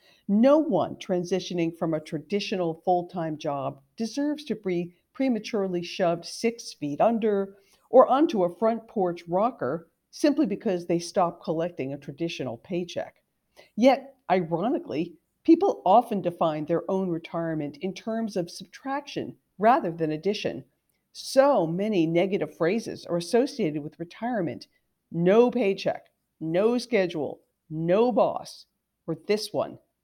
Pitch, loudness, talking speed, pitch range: 185 Hz, -26 LUFS, 125 wpm, 170-225 Hz